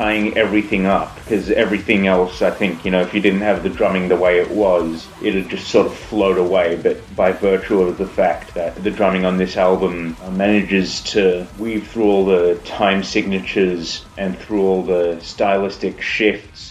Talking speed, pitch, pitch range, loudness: 185 wpm, 95 Hz, 90-100 Hz, -17 LUFS